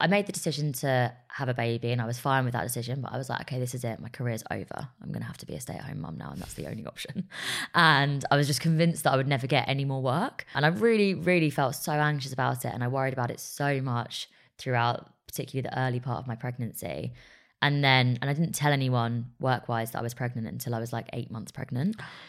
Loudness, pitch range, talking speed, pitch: -28 LUFS, 120-145 Hz, 270 wpm, 130 Hz